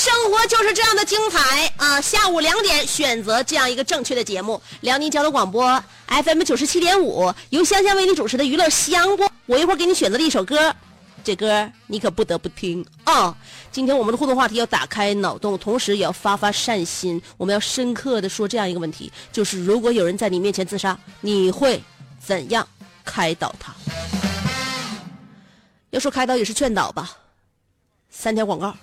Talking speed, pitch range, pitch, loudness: 295 characters per minute, 200-295 Hz, 230 Hz, -19 LUFS